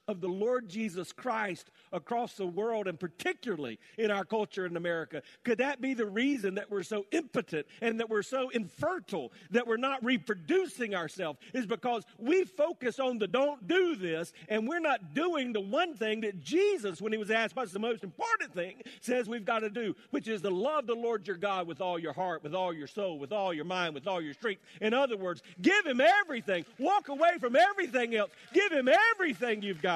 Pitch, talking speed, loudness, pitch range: 225 Hz, 210 wpm, -32 LUFS, 195-270 Hz